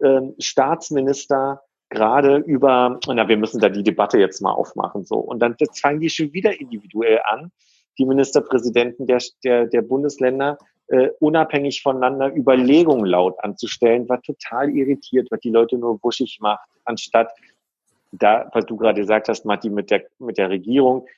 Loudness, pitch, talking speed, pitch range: -19 LUFS, 130 Hz, 150 wpm, 115-140 Hz